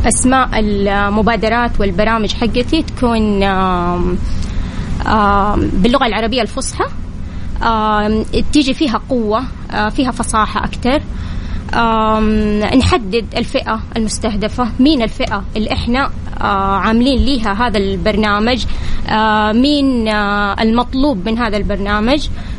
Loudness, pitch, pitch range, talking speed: -15 LUFS, 220 Hz, 205-245 Hz, 90 wpm